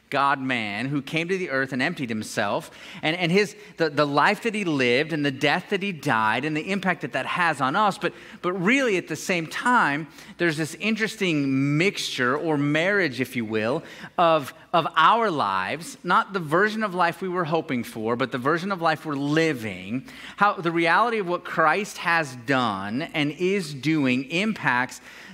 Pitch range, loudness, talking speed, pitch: 135-185 Hz, -24 LUFS, 190 wpm, 160 Hz